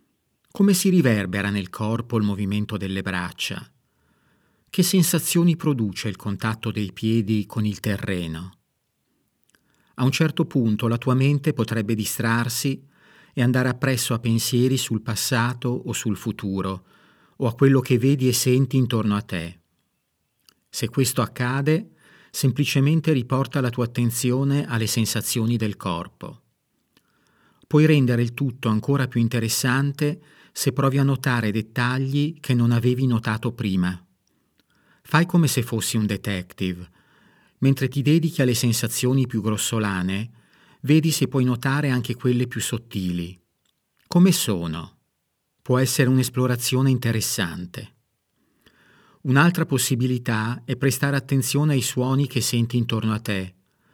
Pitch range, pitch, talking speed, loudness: 110-135 Hz, 125 Hz, 130 wpm, -22 LUFS